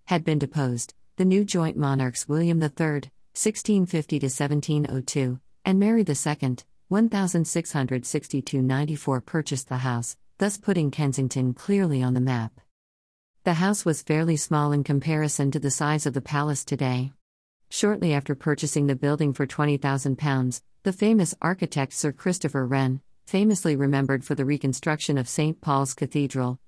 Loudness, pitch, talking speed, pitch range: -25 LUFS, 145 Hz, 140 wpm, 135-160 Hz